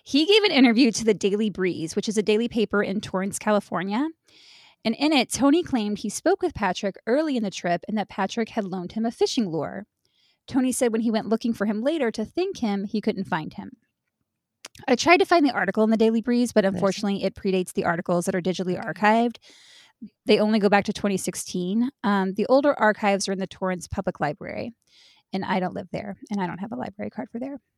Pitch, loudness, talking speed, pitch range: 215 Hz, -24 LUFS, 225 wpm, 195-240 Hz